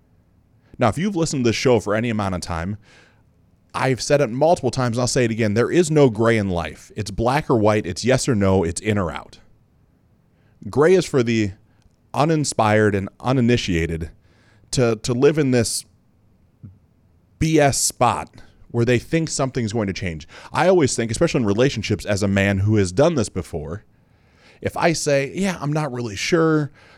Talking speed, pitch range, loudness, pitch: 185 wpm, 100-135 Hz, -20 LUFS, 115 Hz